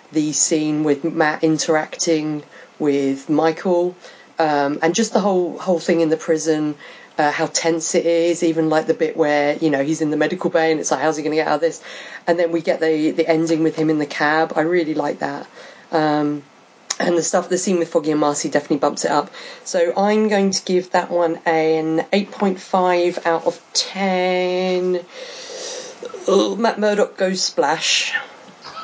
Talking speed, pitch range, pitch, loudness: 190 wpm, 155-180 Hz, 165 Hz, -19 LUFS